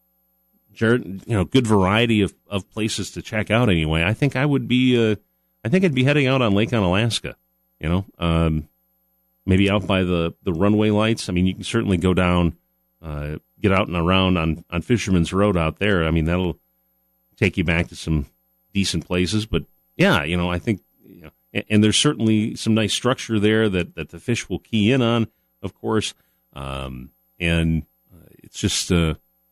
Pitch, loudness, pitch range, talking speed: 90 Hz, -21 LUFS, 80-110 Hz, 195 wpm